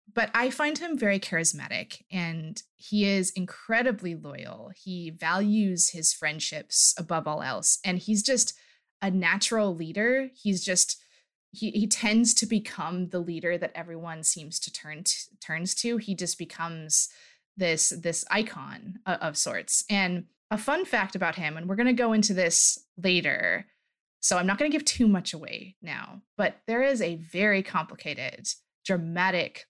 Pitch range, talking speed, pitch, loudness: 170-215 Hz, 160 wpm, 190 Hz, -26 LUFS